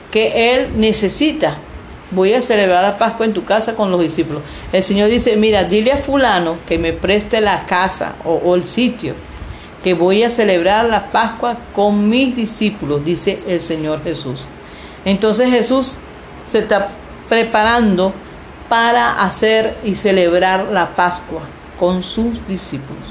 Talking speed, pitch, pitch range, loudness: 150 wpm, 205 Hz, 180-230 Hz, -15 LUFS